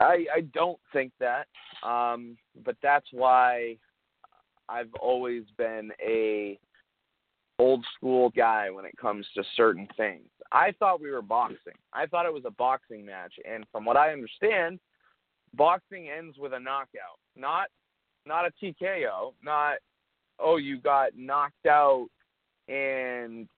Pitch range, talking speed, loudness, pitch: 120-155 Hz, 140 wpm, -27 LUFS, 130 Hz